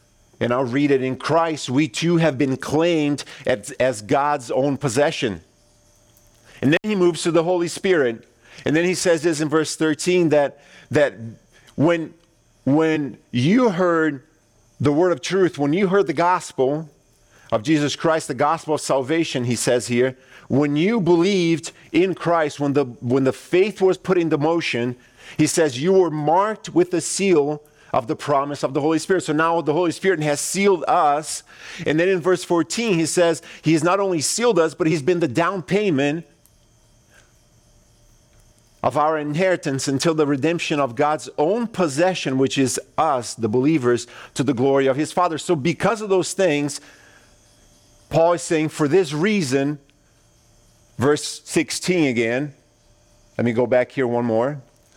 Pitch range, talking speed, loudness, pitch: 130-170 Hz, 170 wpm, -20 LUFS, 150 Hz